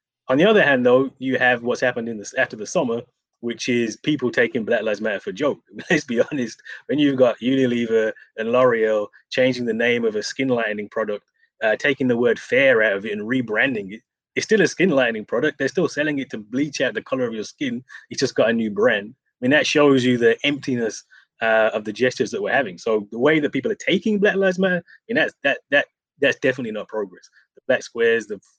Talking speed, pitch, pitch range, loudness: 235 wpm, 130 Hz, 115-185 Hz, -20 LUFS